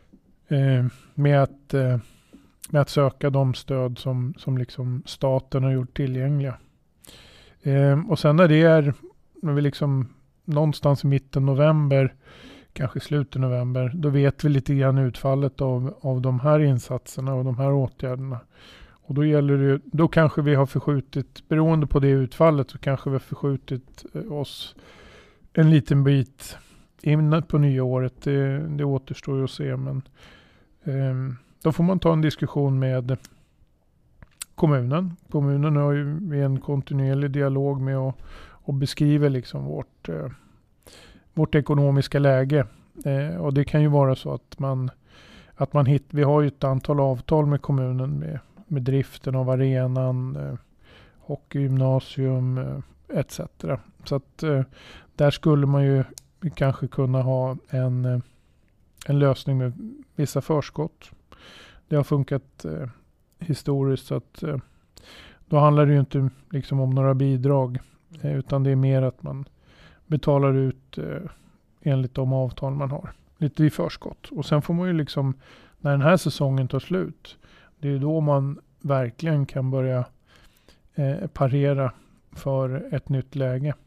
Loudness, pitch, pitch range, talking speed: -23 LUFS, 140 Hz, 130-145 Hz, 150 wpm